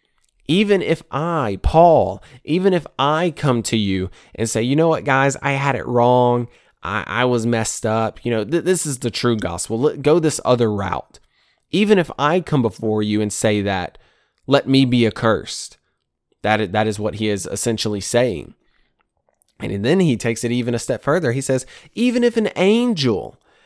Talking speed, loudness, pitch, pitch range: 190 wpm, -18 LUFS, 120 Hz, 110-155 Hz